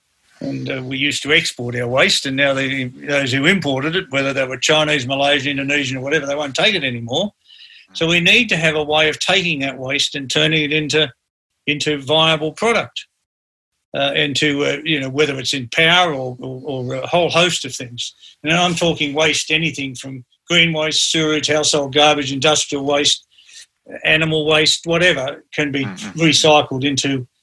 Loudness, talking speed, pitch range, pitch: -16 LUFS, 180 wpm, 135-155 Hz, 145 Hz